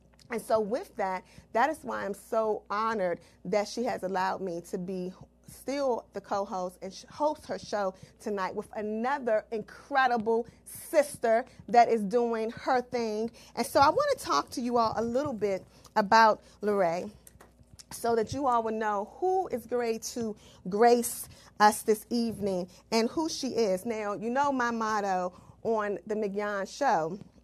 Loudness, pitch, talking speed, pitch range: -29 LUFS, 225 Hz, 165 wpm, 205-240 Hz